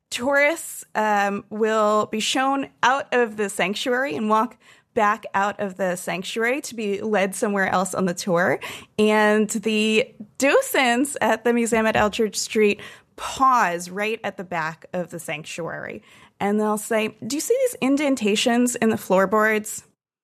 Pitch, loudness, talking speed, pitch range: 215 Hz, -22 LUFS, 155 wpm, 200-240 Hz